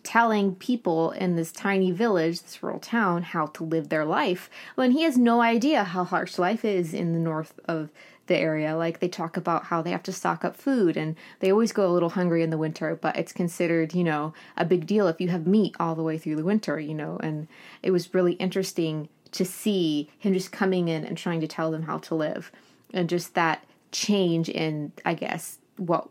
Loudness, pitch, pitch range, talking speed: -26 LUFS, 175 Hz, 160-190 Hz, 225 wpm